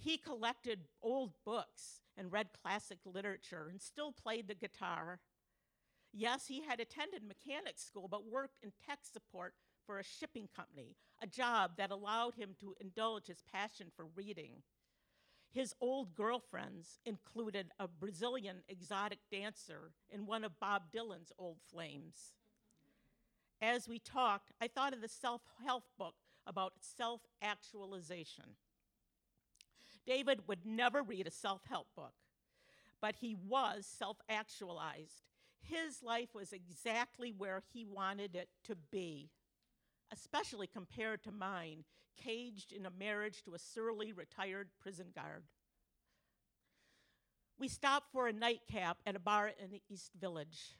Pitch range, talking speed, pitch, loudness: 190-235 Hz, 135 wpm, 210 Hz, -44 LUFS